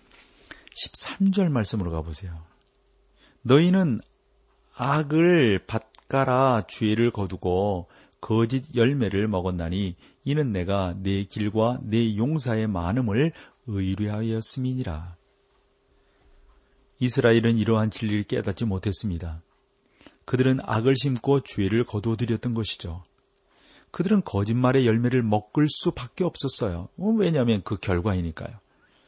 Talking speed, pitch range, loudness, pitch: 250 characters per minute, 100-130 Hz, -24 LUFS, 115 Hz